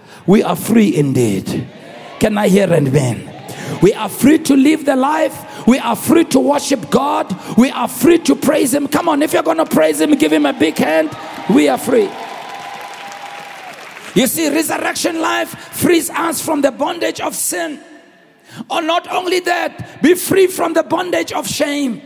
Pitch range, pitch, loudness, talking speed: 220-335 Hz, 290 Hz, -14 LUFS, 180 wpm